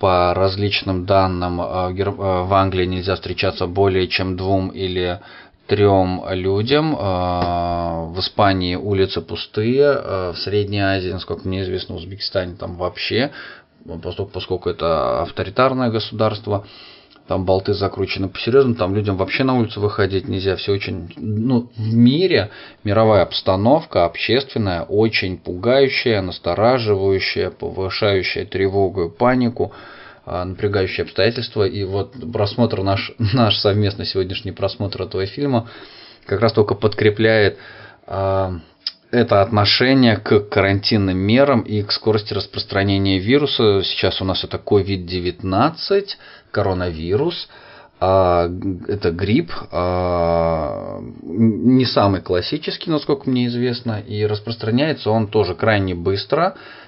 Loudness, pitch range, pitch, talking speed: -19 LUFS, 95-115 Hz, 100 Hz, 110 wpm